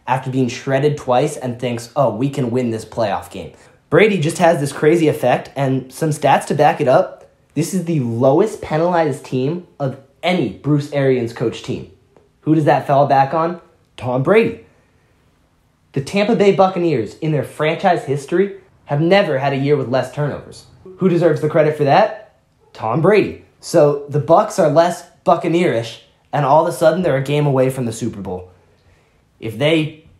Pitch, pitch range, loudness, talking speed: 145 Hz, 130-165 Hz, -17 LUFS, 180 wpm